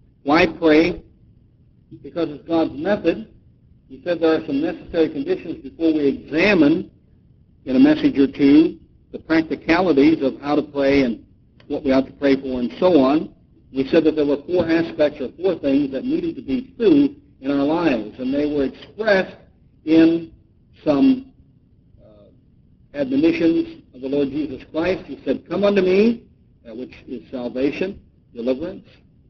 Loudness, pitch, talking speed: -19 LUFS, 165 Hz, 160 wpm